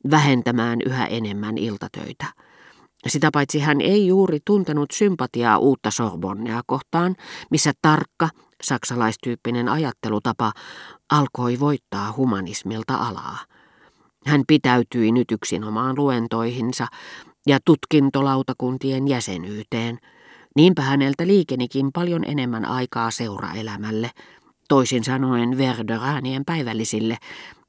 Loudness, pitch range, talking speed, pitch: -21 LUFS, 115-145 Hz, 90 wpm, 125 Hz